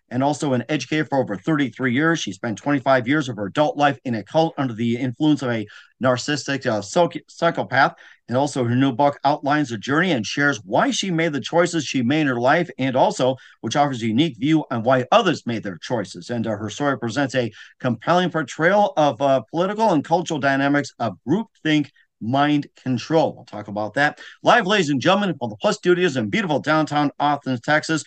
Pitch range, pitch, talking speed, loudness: 125-155 Hz, 145 Hz, 205 wpm, -21 LUFS